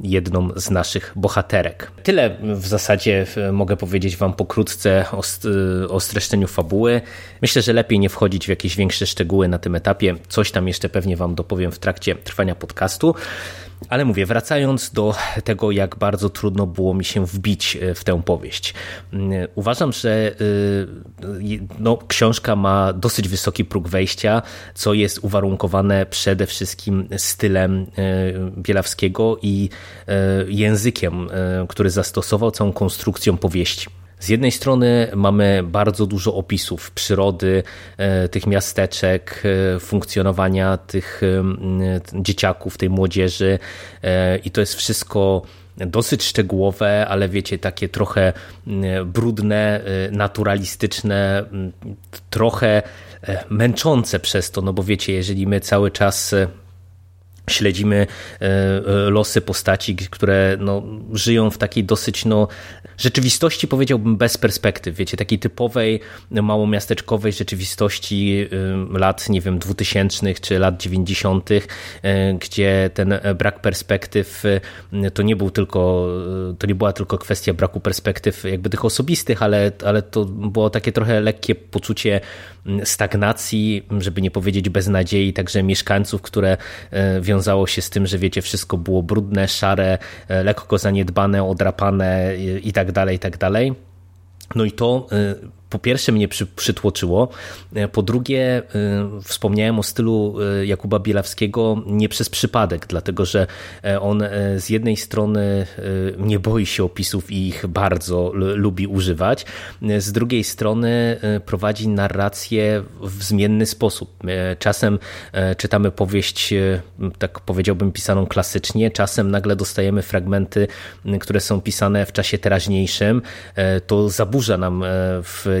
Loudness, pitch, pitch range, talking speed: -19 LUFS, 100 Hz, 95-105 Hz, 125 wpm